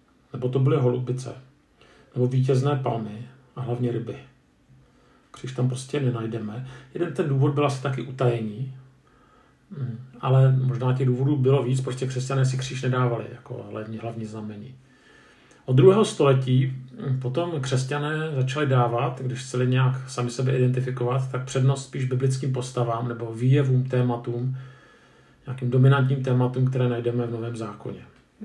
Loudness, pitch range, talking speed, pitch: -24 LUFS, 125-135 Hz, 135 wpm, 130 Hz